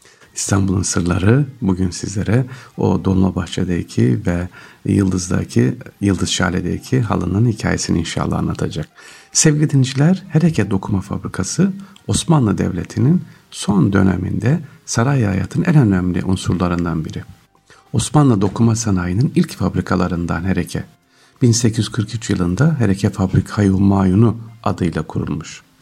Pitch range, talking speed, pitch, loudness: 95-125 Hz, 100 wpm, 100 Hz, -17 LUFS